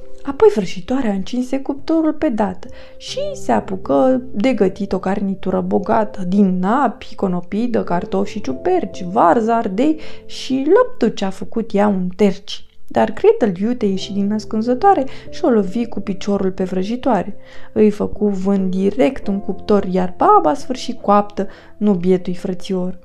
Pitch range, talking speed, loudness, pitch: 195-245 Hz, 145 wpm, -18 LUFS, 210 Hz